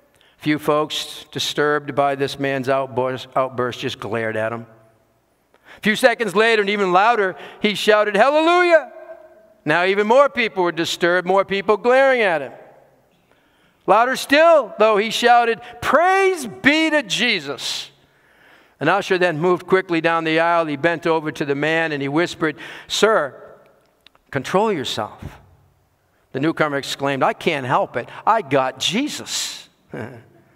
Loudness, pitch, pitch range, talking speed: -18 LUFS, 170 Hz, 140-225 Hz, 140 wpm